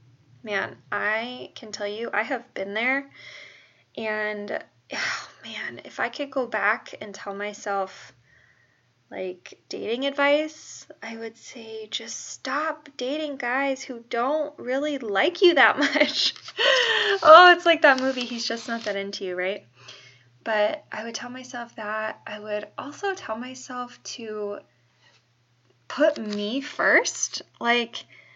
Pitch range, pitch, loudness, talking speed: 205-280 Hz, 230 Hz, -24 LUFS, 140 wpm